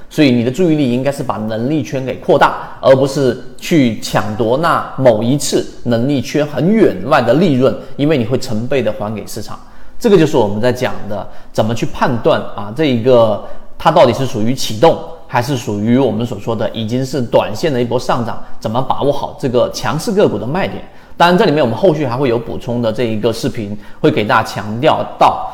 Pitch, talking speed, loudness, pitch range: 125 Hz, 310 characters per minute, -14 LUFS, 110-135 Hz